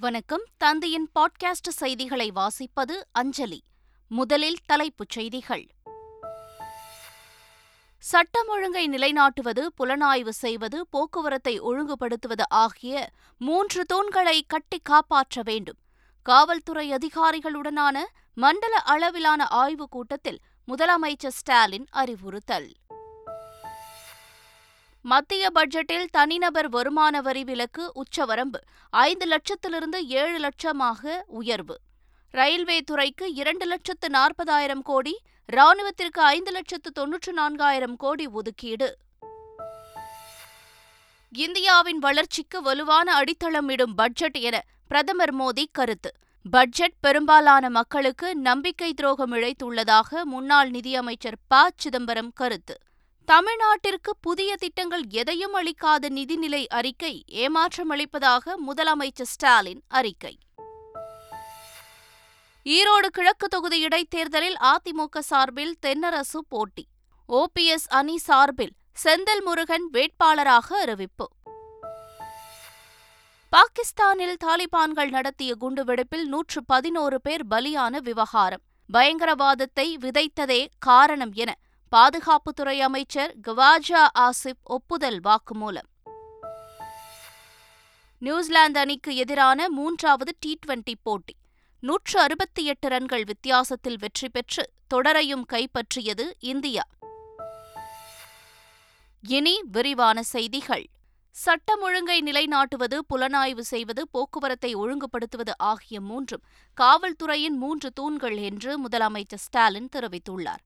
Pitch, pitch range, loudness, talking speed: 285 Hz, 245-330 Hz, -23 LUFS, 85 wpm